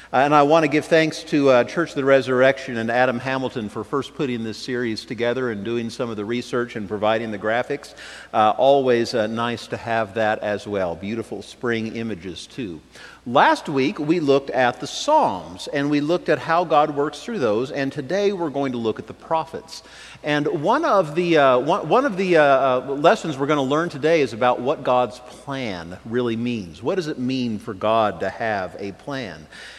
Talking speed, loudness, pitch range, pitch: 205 wpm, -21 LUFS, 115-150 Hz, 130 Hz